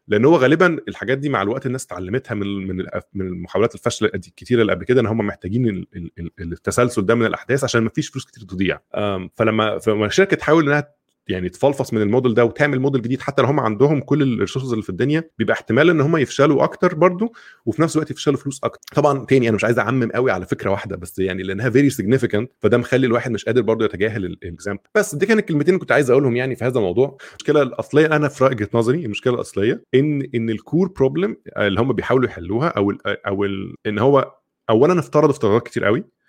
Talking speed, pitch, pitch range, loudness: 210 wpm, 120 Hz, 105-140 Hz, -19 LUFS